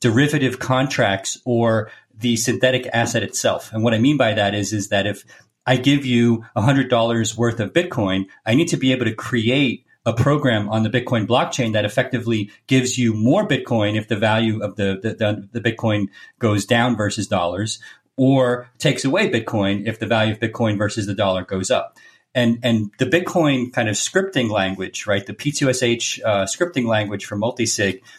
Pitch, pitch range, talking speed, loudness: 115 Hz, 105-125 Hz, 180 wpm, -19 LUFS